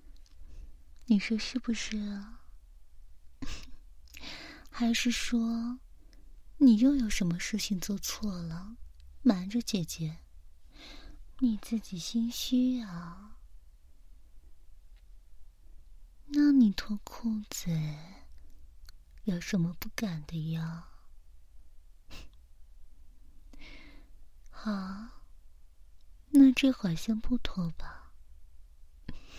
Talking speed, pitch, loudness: 100 characters per minute, 150 Hz, -30 LUFS